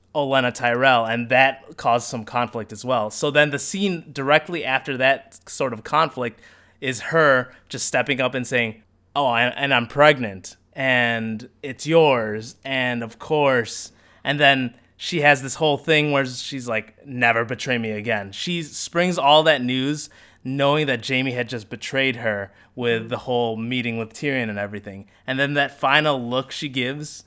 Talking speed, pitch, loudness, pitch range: 170 wpm, 130 Hz, -21 LUFS, 115-140 Hz